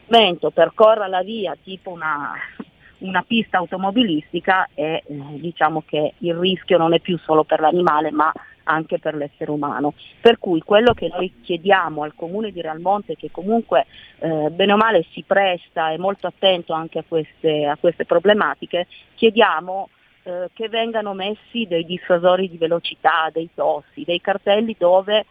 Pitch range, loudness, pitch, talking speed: 160-195 Hz, -19 LUFS, 175 Hz, 155 wpm